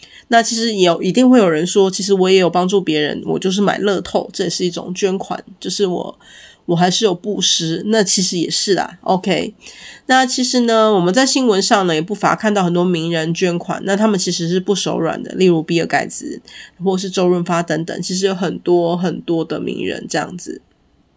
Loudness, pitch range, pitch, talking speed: -16 LUFS, 170-205 Hz, 185 Hz, 305 characters per minute